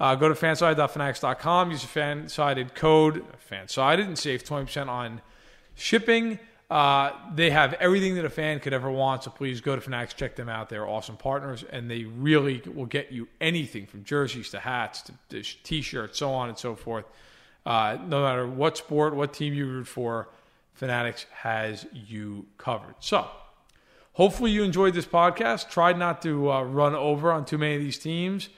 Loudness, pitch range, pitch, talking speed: -26 LUFS, 125-160 Hz, 140 Hz, 180 wpm